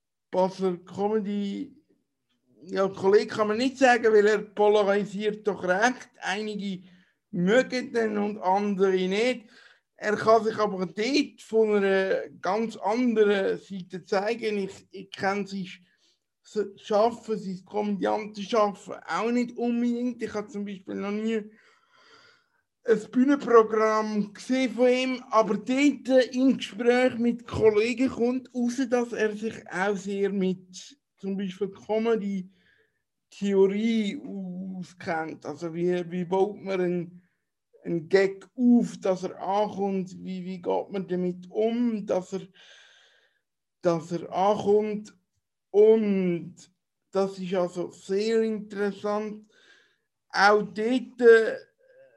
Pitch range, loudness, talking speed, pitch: 190-230 Hz, -26 LUFS, 125 wpm, 210 Hz